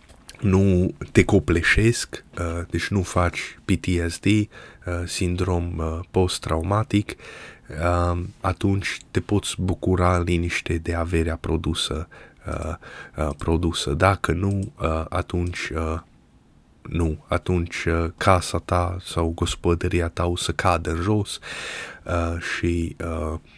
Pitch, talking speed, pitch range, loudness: 85 Hz, 115 wpm, 85-95 Hz, -24 LUFS